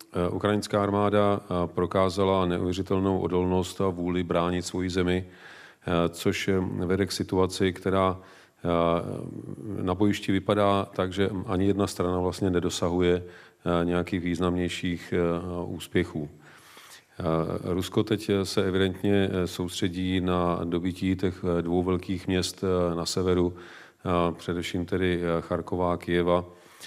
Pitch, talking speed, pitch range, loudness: 90 Hz, 105 wpm, 90-95 Hz, -27 LUFS